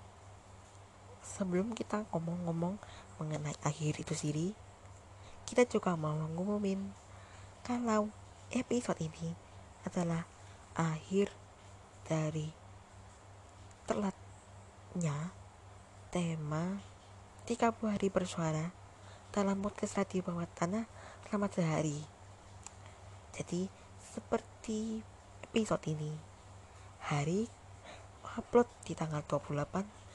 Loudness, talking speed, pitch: -37 LUFS, 75 wpm, 155 Hz